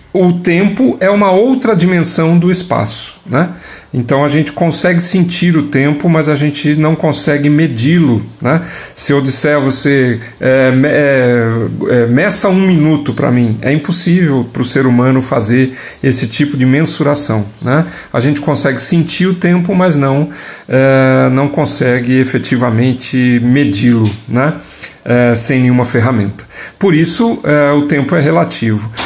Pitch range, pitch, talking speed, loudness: 125-160 Hz, 145 Hz, 155 wpm, -11 LUFS